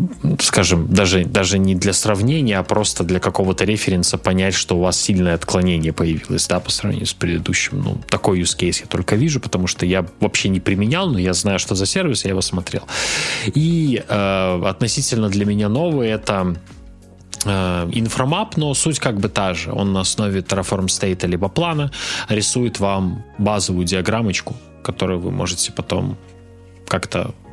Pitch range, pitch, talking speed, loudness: 90-110 Hz, 95 Hz, 165 wpm, -18 LUFS